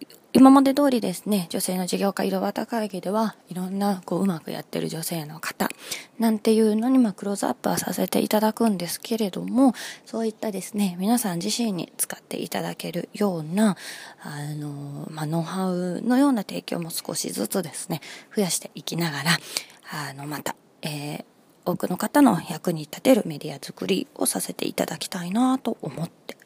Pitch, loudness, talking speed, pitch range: 195 Hz, -24 LUFS, 370 characters per minute, 170-225 Hz